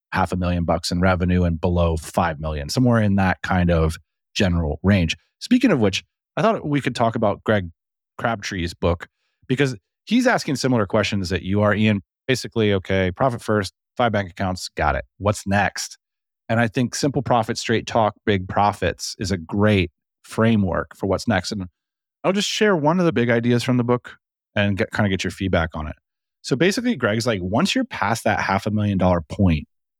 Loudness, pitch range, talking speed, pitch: -21 LUFS, 90-120 Hz, 200 wpm, 105 Hz